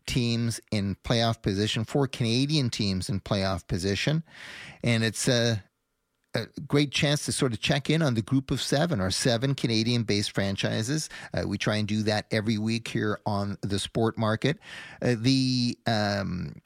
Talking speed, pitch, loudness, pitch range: 170 wpm, 115 Hz, -27 LUFS, 105-130 Hz